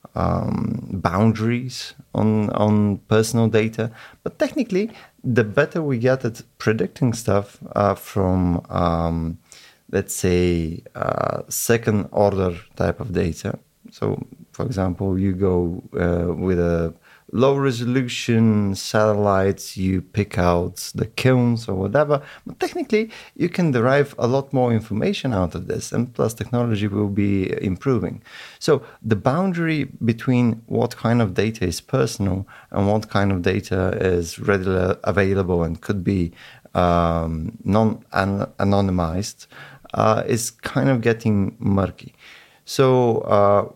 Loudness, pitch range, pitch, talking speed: -21 LUFS, 95-120 Hz, 105 Hz, 130 wpm